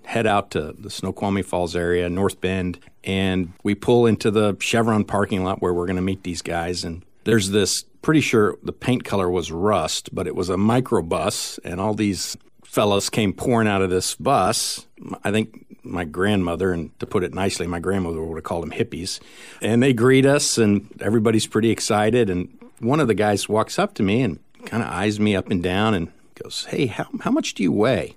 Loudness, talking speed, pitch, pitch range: -21 LUFS, 210 wpm, 100 Hz, 90-110 Hz